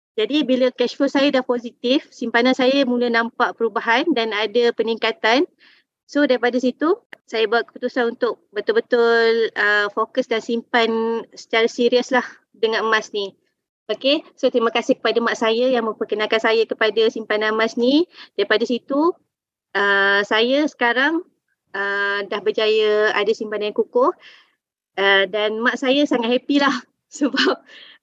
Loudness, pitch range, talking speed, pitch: -19 LUFS, 220-260 Hz, 145 wpm, 235 Hz